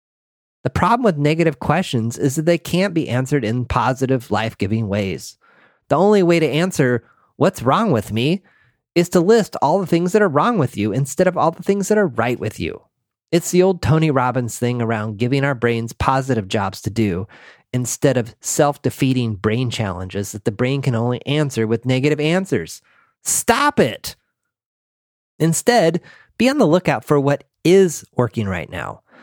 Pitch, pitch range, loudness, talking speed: 135 Hz, 115-170 Hz, -18 LUFS, 180 wpm